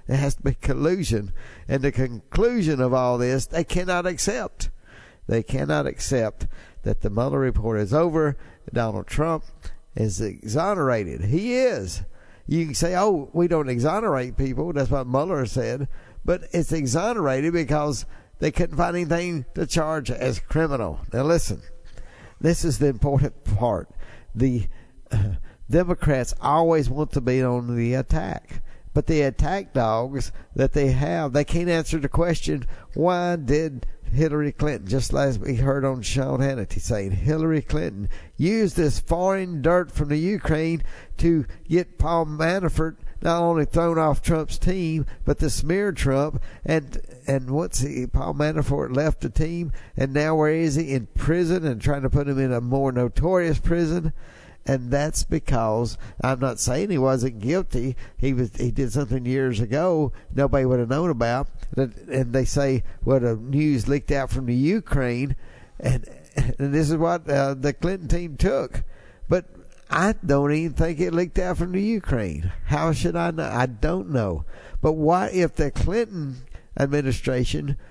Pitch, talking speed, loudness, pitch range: 140 Hz, 160 wpm, -24 LUFS, 125-165 Hz